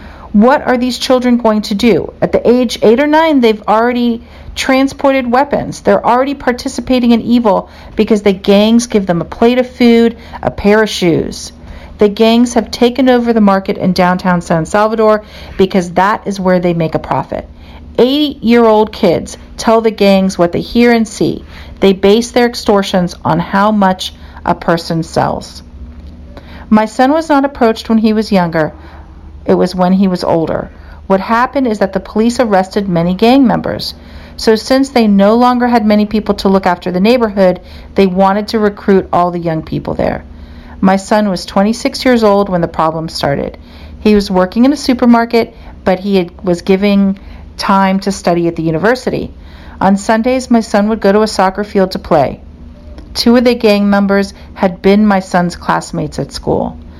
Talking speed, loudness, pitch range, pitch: 185 wpm, -11 LUFS, 180-235 Hz, 205 Hz